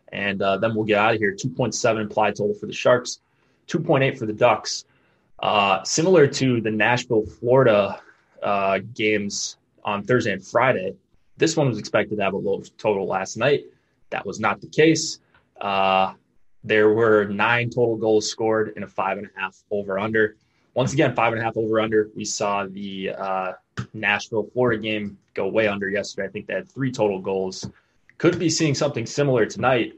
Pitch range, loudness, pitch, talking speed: 100-120 Hz, -22 LUFS, 110 Hz, 185 wpm